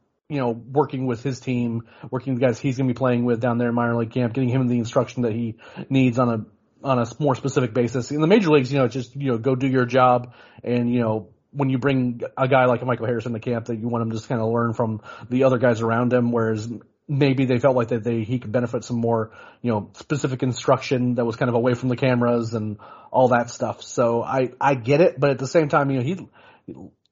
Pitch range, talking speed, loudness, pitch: 120-135 Hz, 265 wpm, -22 LUFS, 125 Hz